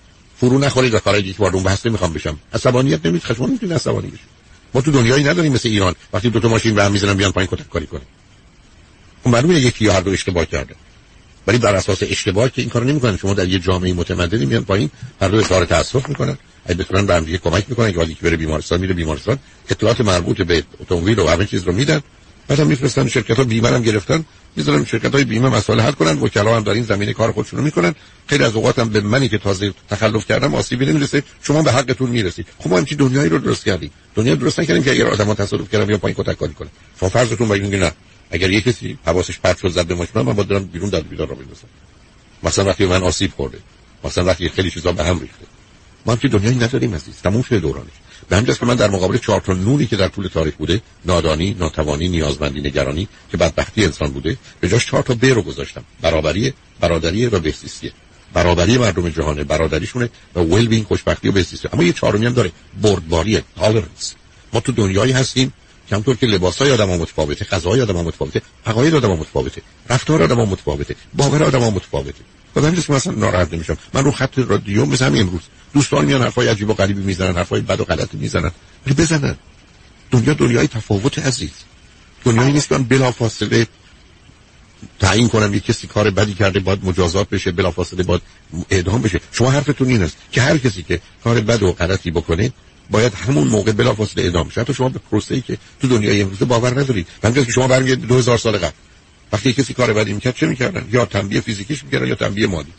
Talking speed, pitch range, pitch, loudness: 210 wpm, 90-120 Hz, 105 Hz, -17 LUFS